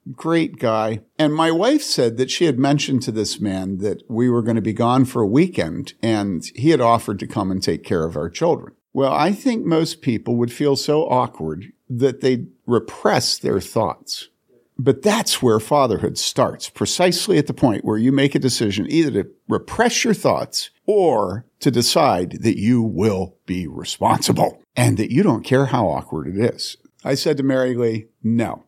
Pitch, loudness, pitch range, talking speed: 130 Hz, -19 LUFS, 110-150 Hz, 190 wpm